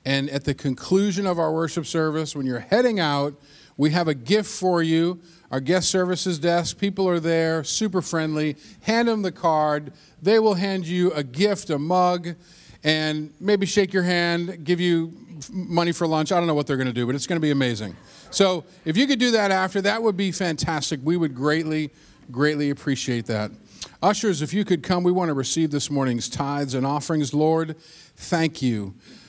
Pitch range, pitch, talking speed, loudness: 145-185 Hz, 165 Hz, 200 wpm, -23 LUFS